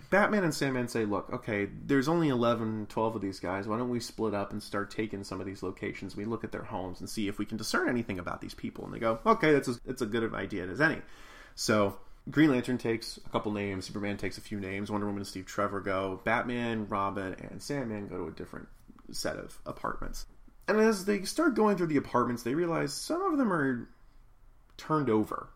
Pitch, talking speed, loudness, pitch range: 110 Hz, 230 wpm, -31 LUFS, 100-130 Hz